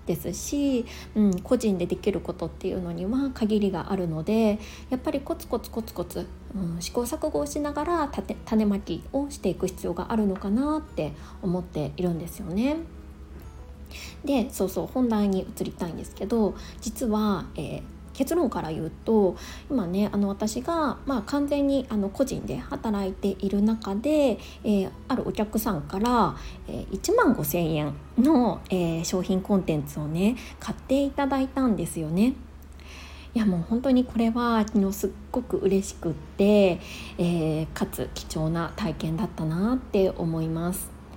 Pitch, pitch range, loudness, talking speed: 205 Hz, 175-245 Hz, -27 LUFS, 310 characters per minute